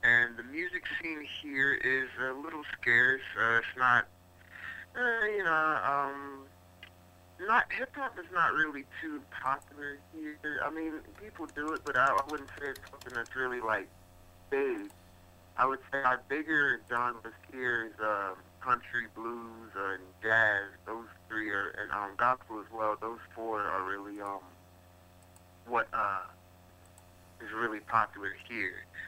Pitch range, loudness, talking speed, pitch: 90-140 Hz, -32 LUFS, 145 wpm, 115 Hz